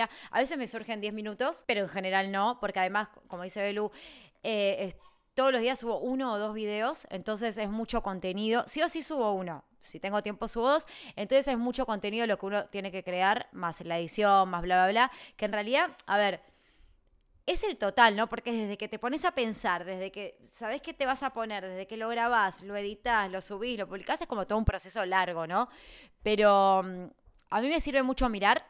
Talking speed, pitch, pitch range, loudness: 215 wpm, 215 Hz, 195-245 Hz, -30 LUFS